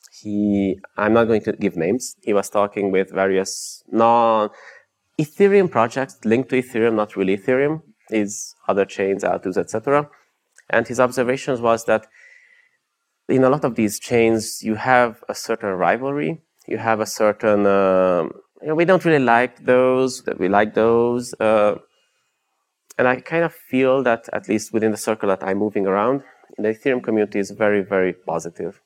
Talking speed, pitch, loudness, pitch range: 165 wpm, 110 Hz, -19 LUFS, 105-130 Hz